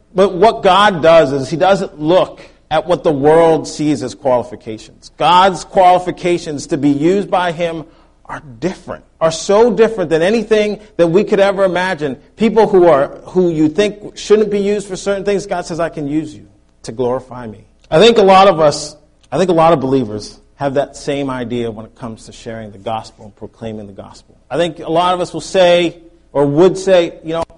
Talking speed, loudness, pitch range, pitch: 205 wpm, -13 LUFS, 140-185 Hz, 165 Hz